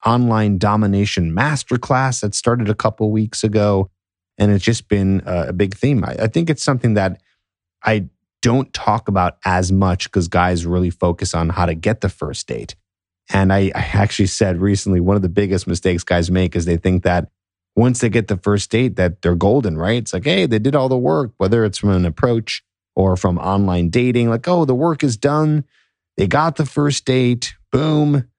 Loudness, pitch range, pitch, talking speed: -17 LUFS, 90-120 Hz, 100 Hz, 205 wpm